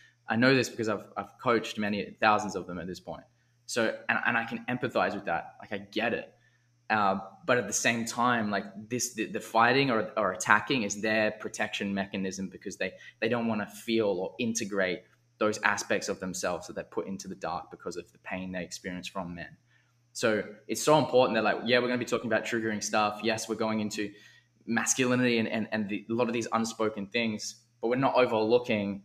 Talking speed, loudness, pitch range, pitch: 215 wpm, -29 LUFS, 100-120 Hz, 110 Hz